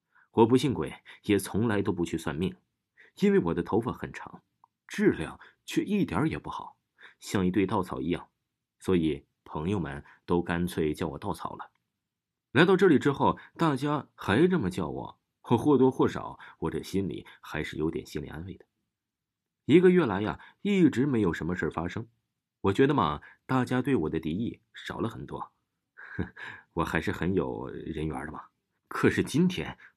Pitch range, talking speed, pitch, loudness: 85-145 Hz, 240 characters per minute, 115 Hz, -28 LUFS